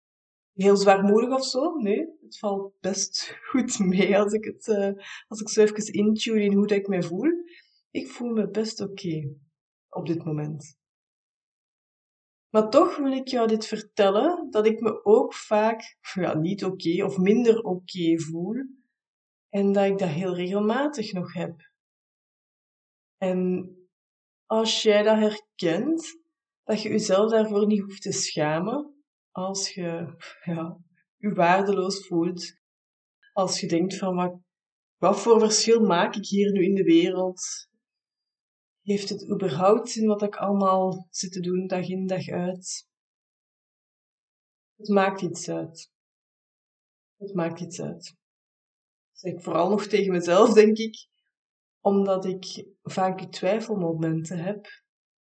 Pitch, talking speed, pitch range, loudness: 200 Hz, 145 wpm, 180-220 Hz, -24 LUFS